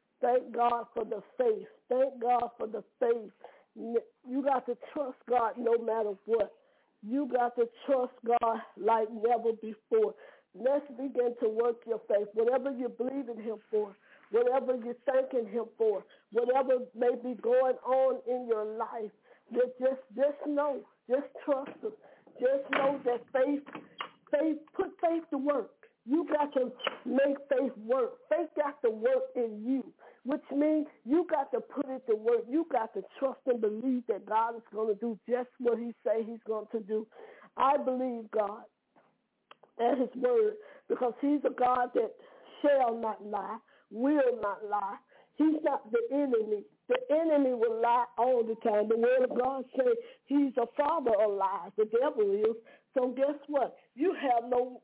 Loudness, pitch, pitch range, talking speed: -31 LUFS, 255 Hz, 230-285 Hz, 170 wpm